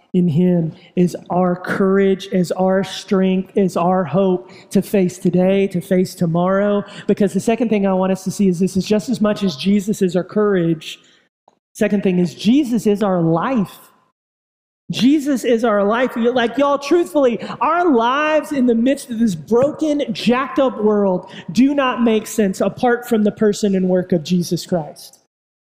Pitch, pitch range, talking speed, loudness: 200 Hz, 185-235 Hz, 175 wpm, -17 LUFS